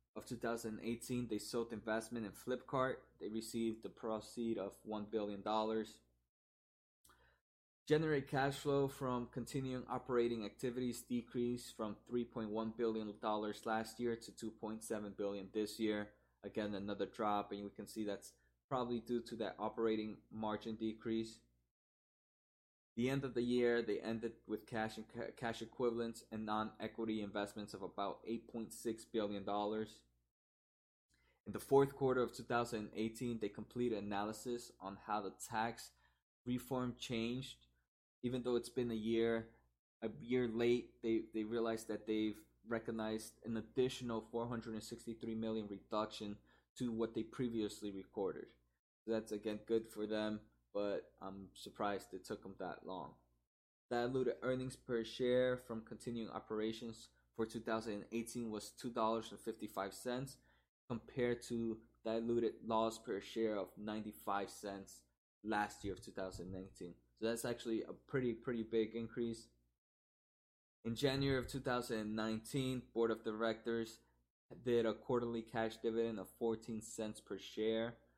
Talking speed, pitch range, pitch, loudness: 140 wpm, 105-120 Hz, 110 Hz, -42 LUFS